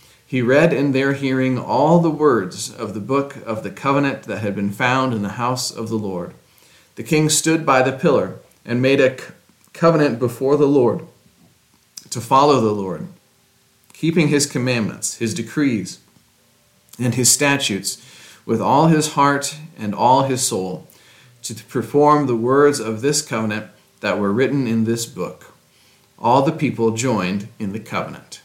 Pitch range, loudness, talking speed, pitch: 115-140 Hz, -18 LUFS, 160 wpm, 130 Hz